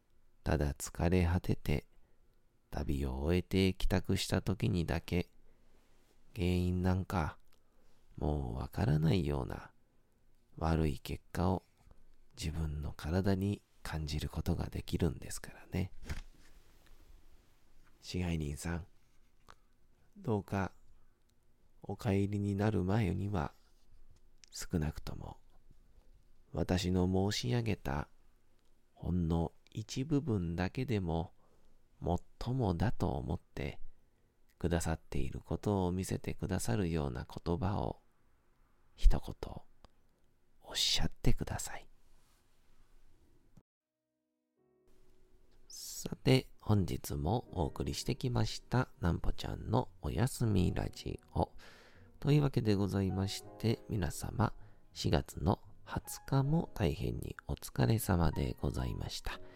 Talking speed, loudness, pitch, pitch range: 200 characters per minute, -36 LUFS, 90 Hz, 80-110 Hz